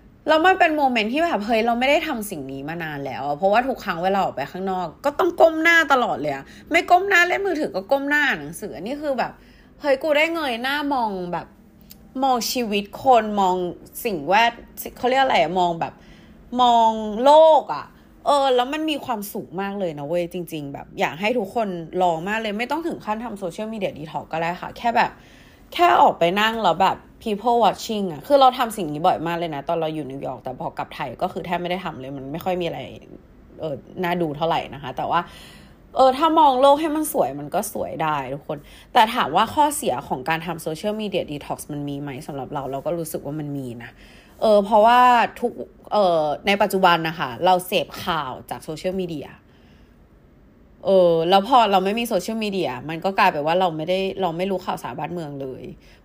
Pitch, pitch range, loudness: 190 Hz, 165-245 Hz, -21 LUFS